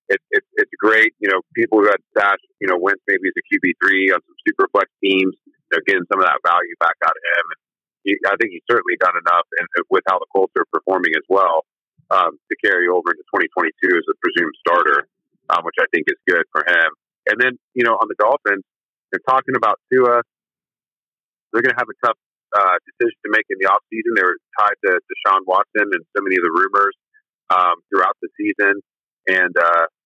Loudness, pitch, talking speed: -17 LUFS, 370 Hz, 220 wpm